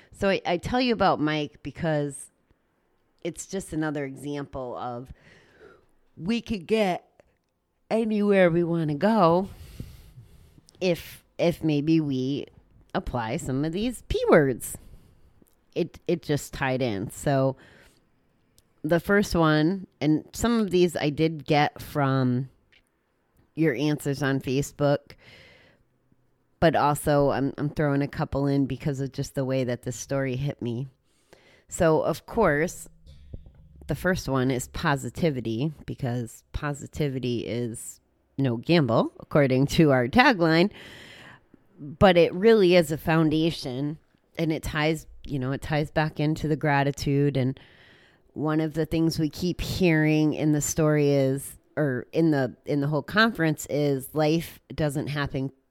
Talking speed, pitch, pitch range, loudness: 135 wpm, 150 Hz, 135-165 Hz, -25 LUFS